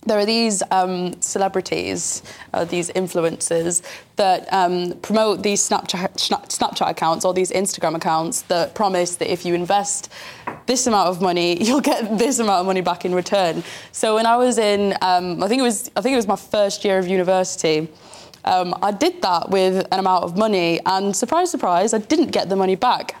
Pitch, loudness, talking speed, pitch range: 190 Hz, -19 LUFS, 195 wpm, 180-215 Hz